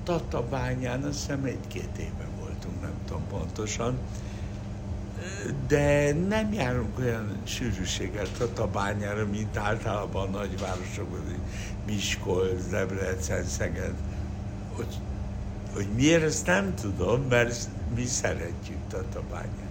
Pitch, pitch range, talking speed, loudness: 100 Hz, 95-115 Hz, 100 wpm, -30 LUFS